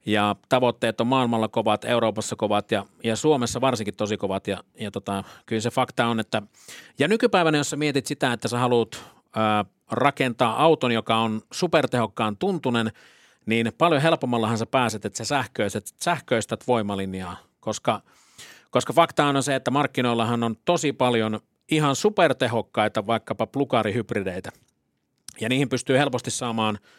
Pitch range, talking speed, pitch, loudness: 110-135 Hz, 145 wpm, 120 Hz, -24 LUFS